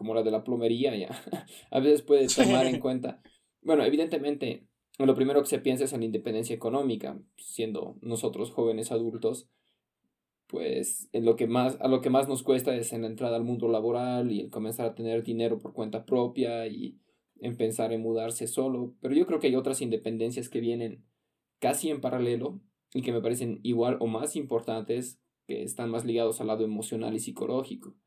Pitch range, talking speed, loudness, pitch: 115-130 Hz, 190 wpm, -29 LUFS, 120 Hz